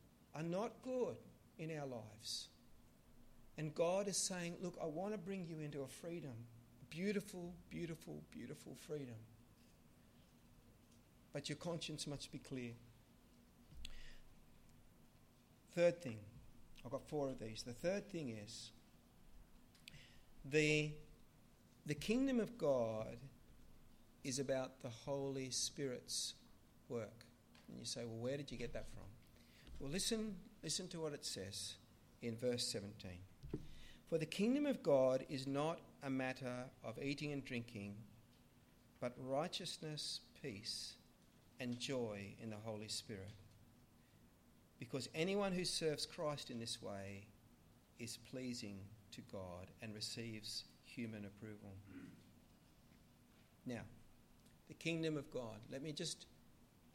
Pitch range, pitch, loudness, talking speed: 115-155 Hz, 125 Hz, -45 LUFS, 125 wpm